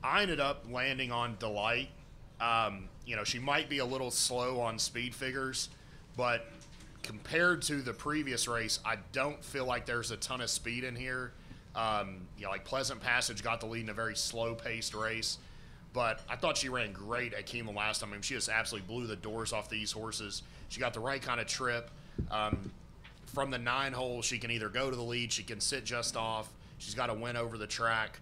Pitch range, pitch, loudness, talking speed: 110-130 Hz, 120 Hz, -35 LUFS, 215 wpm